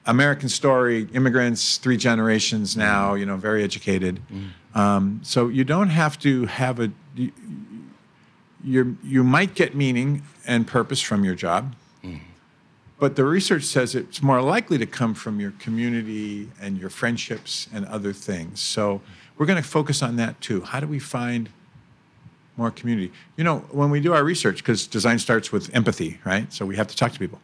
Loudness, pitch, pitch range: -22 LUFS, 120 Hz, 105-140 Hz